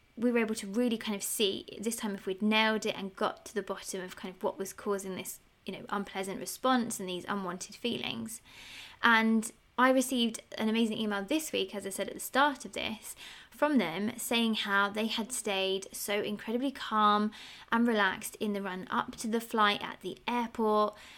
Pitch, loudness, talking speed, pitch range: 215 Hz, -31 LUFS, 205 wpm, 200-230 Hz